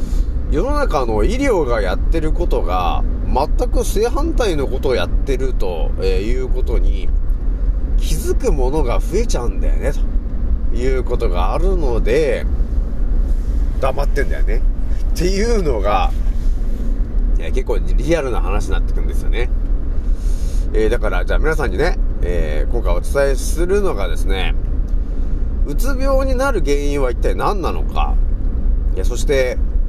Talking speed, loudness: 270 characters per minute, -20 LUFS